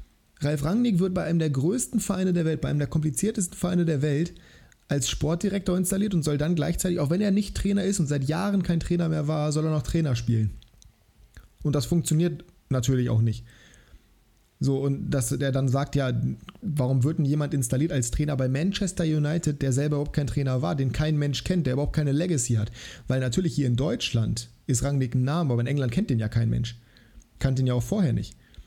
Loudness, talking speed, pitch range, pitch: -26 LUFS, 215 wpm, 130-170 Hz, 150 Hz